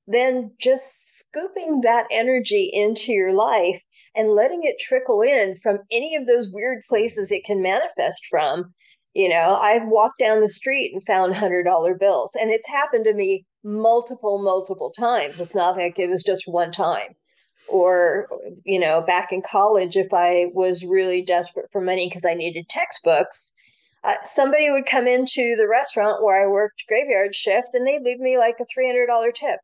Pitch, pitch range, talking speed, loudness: 215 Hz, 190-260 Hz, 175 wpm, -20 LUFS